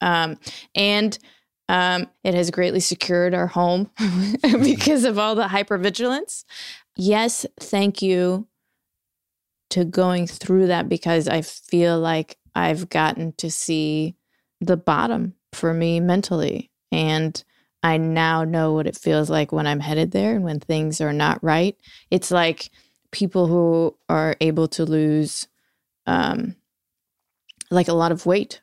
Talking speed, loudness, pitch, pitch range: 140 wpm, -21 LUFS, 175 Hz, 160-195 Hz